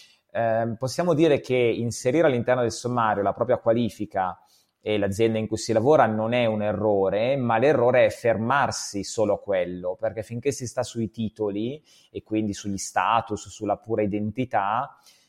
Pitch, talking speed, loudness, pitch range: 110 Hz, 160 wpm, -24 LUFS, 105-120 Hz